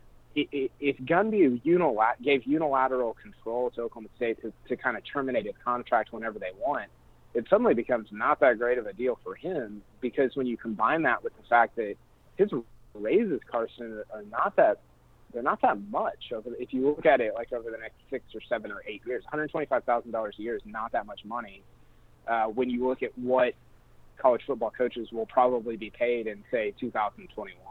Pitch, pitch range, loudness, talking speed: 125 Hz, 115-135 Hz, -28 LUFS, 195 wpm